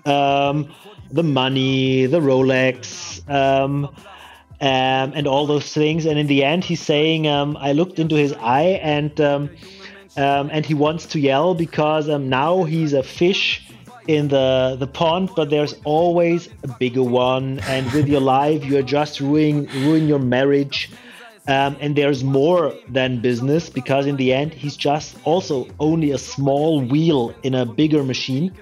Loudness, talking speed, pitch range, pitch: -19 LUFS, 165 wpm, 135-155 Hz, 145 Hz